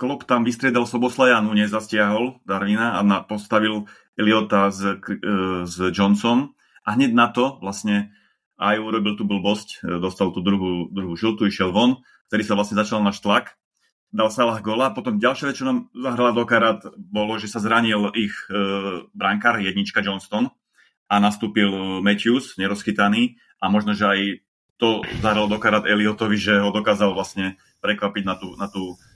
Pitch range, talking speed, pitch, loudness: 100-115 Hz, 150 wpm, 105 Hz, -21 LUFS